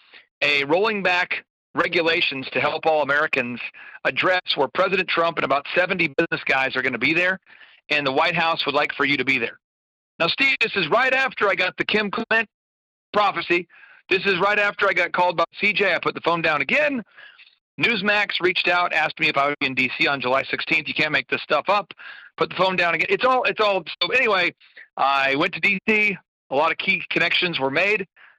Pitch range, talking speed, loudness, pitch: 145-195 Hz, 215 wpm, -20 LUFS, 175 Hz